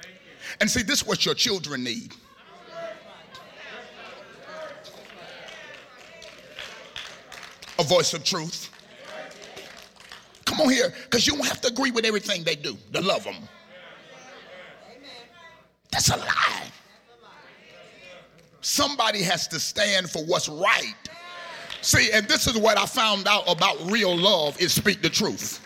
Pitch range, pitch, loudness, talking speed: 180-270 Hz, 205 Hz, -22 LUFS, 125 wpm